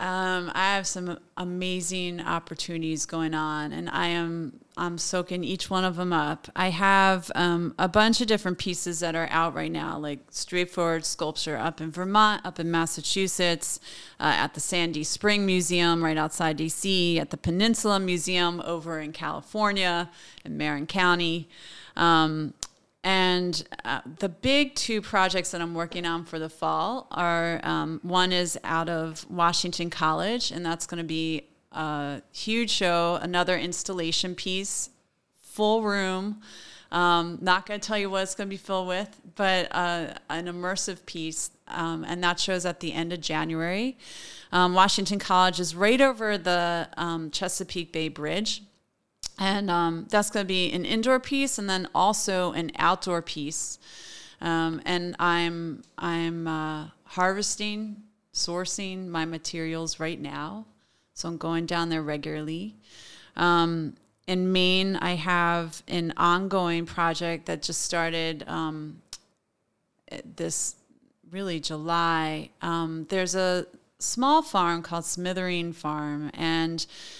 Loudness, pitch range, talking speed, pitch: -26 LUFS, 165-190 Hz, 145 wpm, 175 Hz